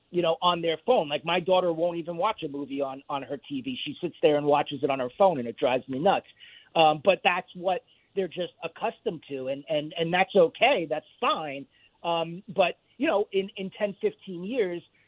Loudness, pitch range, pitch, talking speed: -27 LUFS, 145-195 Hz, 170 Hz, 220 wpm